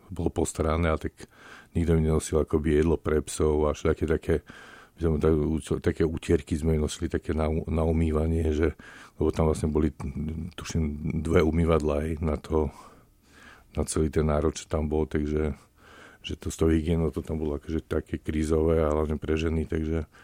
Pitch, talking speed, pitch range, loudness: 80 Hz, 180 wpm, 75-80 Hz, -27 LUFS